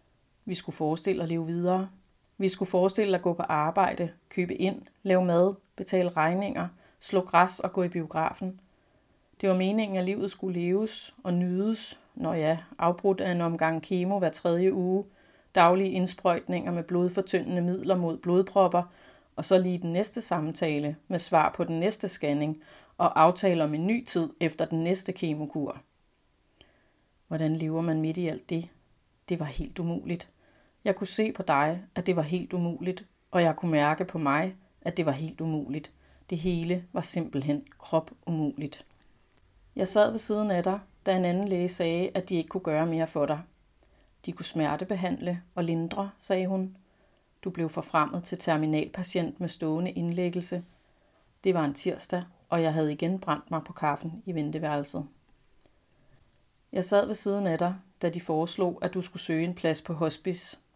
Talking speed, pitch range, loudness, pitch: 175 wpm, 160-190 Hz, -29 LUFS, 175 Hz